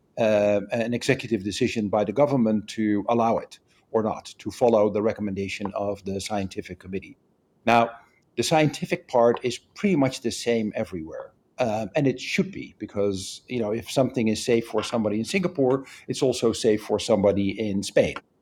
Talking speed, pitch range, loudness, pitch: 175 wpm, 105-125 Hz, -25 LUFS, 115 Hz